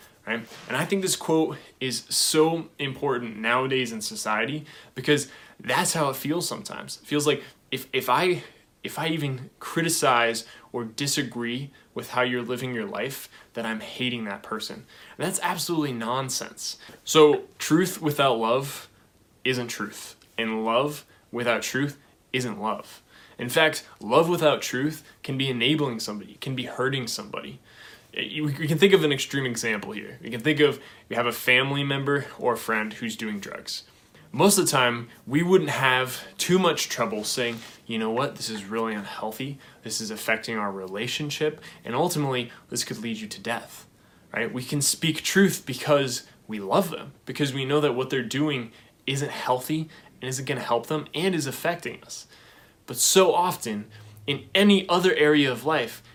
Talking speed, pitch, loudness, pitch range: 170 wpm, 130 Hz, -25 LUFS, 120-150 Hz